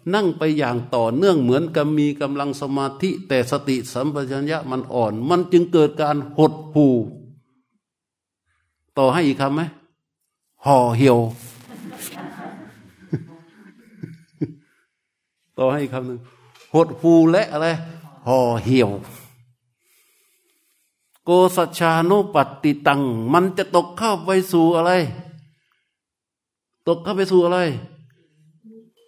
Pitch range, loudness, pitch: 130-170 Hz, -19 LUFS, 155 Hz